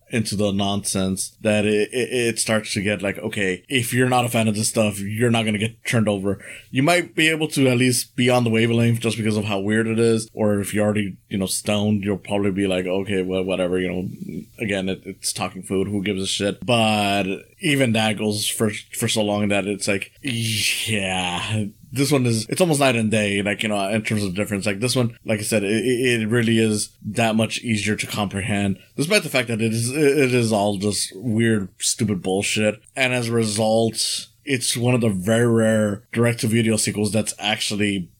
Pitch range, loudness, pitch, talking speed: 100-115 Hz, -21 LUFS, 110 Hz, 220 wpm